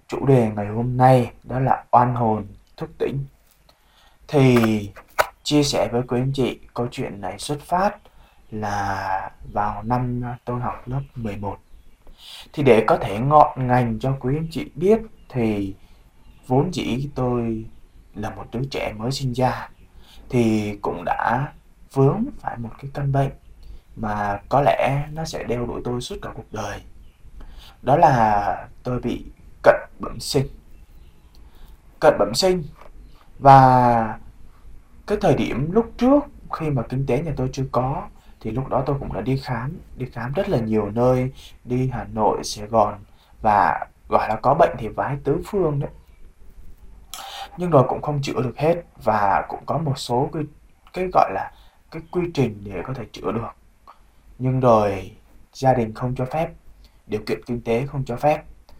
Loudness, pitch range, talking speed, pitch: -21 LUFS, 105-140 Hz, 165 wpm, 125 Hz